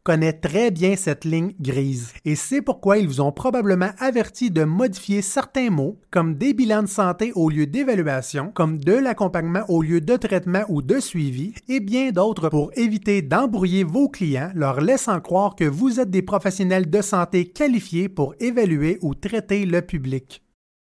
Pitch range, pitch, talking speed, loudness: 160-220 Hz, 185 Hz, 175 wpm, -21 LUFS